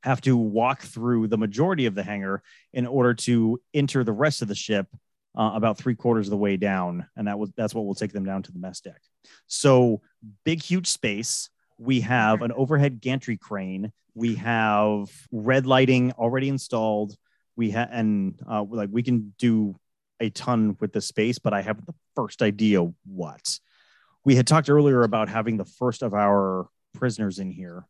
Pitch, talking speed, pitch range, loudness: 115 Hz, 190 wpm, 105-125 Hz, -24 LUFS